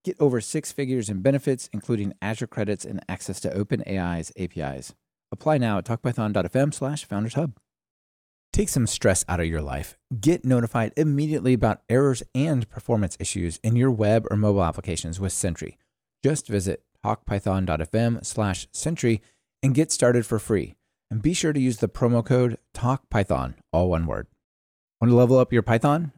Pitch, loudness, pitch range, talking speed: 115 Hz, -24 LUFS, 95-130 Hz, 165 wpm